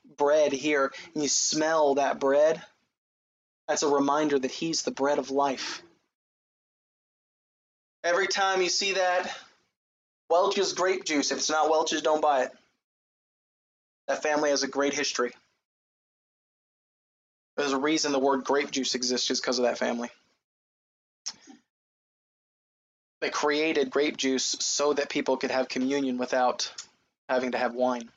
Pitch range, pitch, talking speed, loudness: 135-155 Hz, 145 Hz, 140 wpm, -26 LUFS